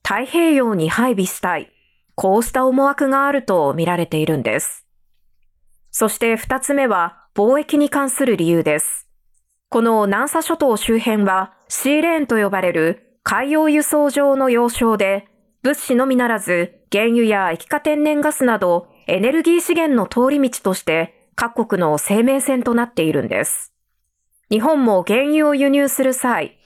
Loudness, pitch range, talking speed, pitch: -17 LUFS, 190-275 Hz, 295 characters per minute, 235 Hz